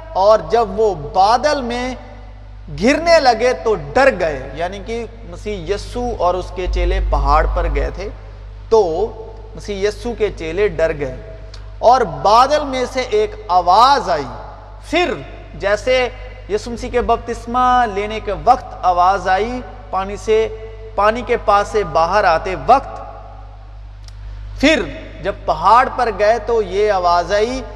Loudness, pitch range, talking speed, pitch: -16 LUFS, 165-240 Hz, 140 wpm, 210 Hz